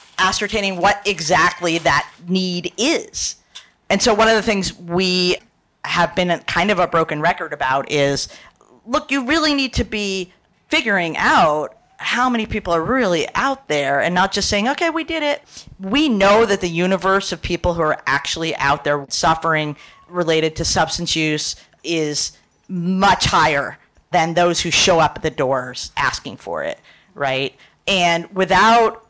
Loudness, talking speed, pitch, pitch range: -18 LUFS, 165 wpm, 180 Hz, 160-210 Hz